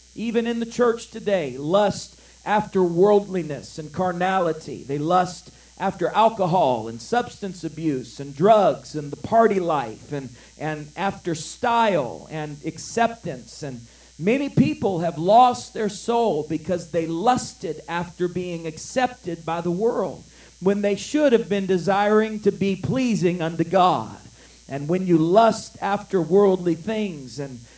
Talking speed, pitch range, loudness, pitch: 140 wpm, 160-210 Hz, -22 LUFS, 185 Hz